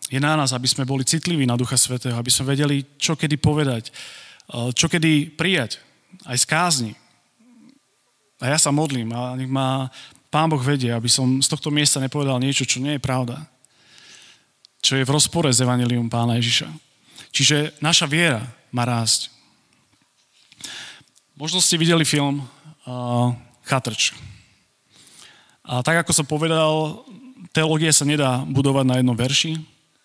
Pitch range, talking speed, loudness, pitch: 125-155 Hz, 150 wpm, -19 LUFS, 140 Hz